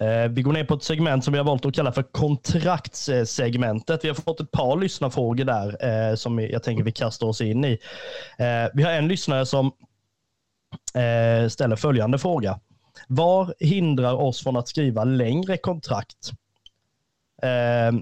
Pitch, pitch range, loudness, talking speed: 130 Hz, 115-150 Hz, -23 LUFS, 150 wpm